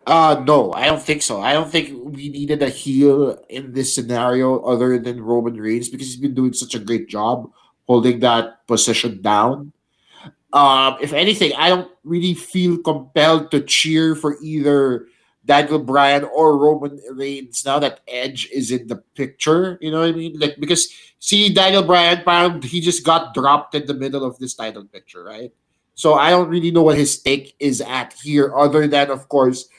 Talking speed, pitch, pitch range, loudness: 190 wpm, 140 Hz, 130-160 Hz, -17 LUFS